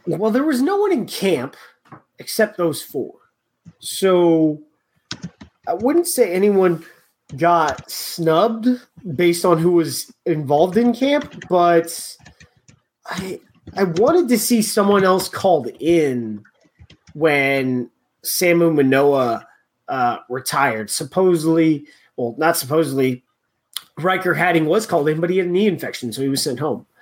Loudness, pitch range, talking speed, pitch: -18 LUFS, 155-205 Hz, 130 wpm, 170 Hz